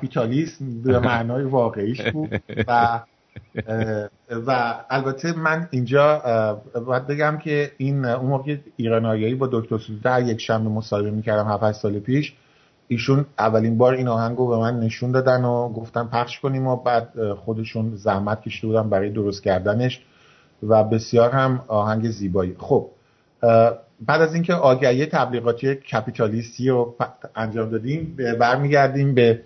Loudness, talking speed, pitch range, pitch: -21 LUFS, 135 wpm, 110-135 Hz, 120 Hz